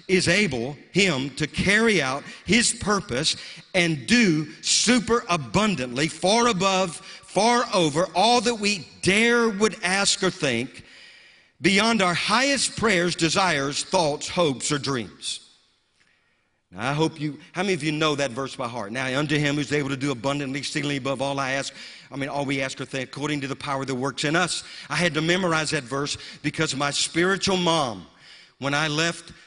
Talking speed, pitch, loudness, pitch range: 175 wpm, 160 Hz, -23 LUFS, 140-190 Hz